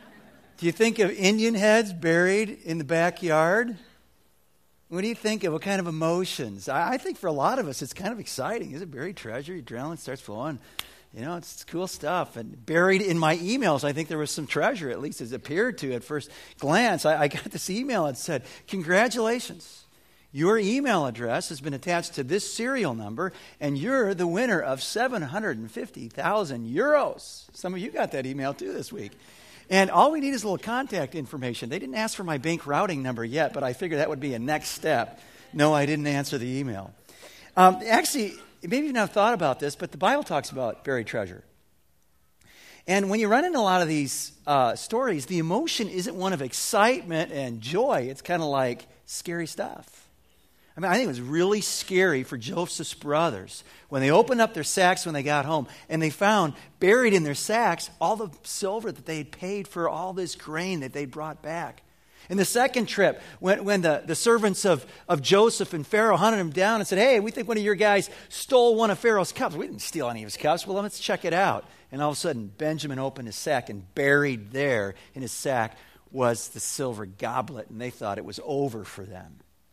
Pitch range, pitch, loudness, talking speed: 135-200 Hz, 165 Hz, -26 LUFS, 215 wpm